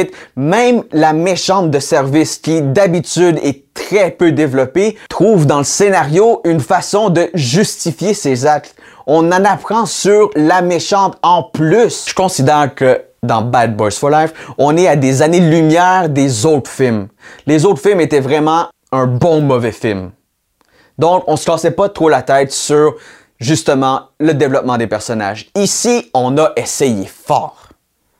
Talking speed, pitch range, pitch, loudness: 155 wpm, 135-180 Hz, 155 Hz, -12 LUFS